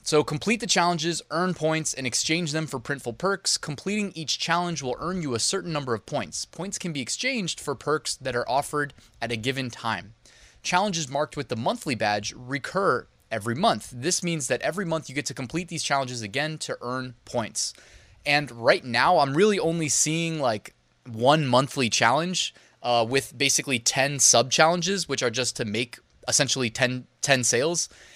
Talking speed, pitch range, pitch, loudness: 185 wpm, 125-165 Hz, 145 Hz, -25 LUFS